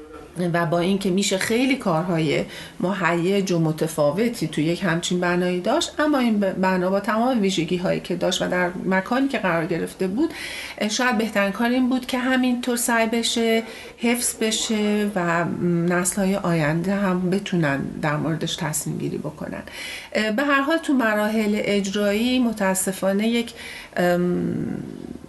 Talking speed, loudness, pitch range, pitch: 140 wpm, -22 LUFS, 175-235 Hz, 195 Hz